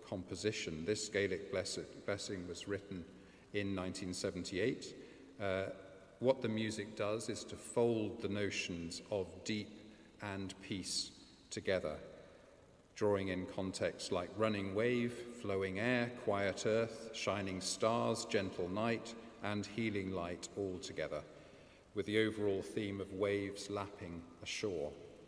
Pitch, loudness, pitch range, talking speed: 100 Hz, -40 LUFS, 95-110 Hz, 120 wpm